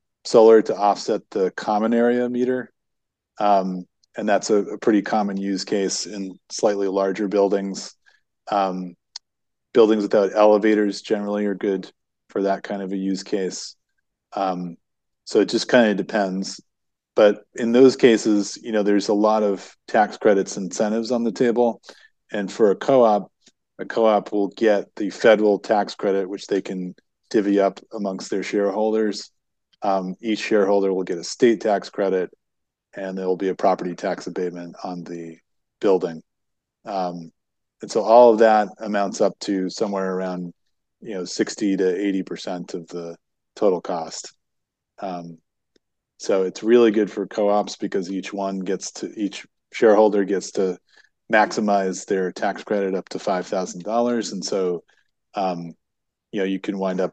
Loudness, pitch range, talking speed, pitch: -21 LUFS, 95-105 Hz, 160 wpm, 100 Hz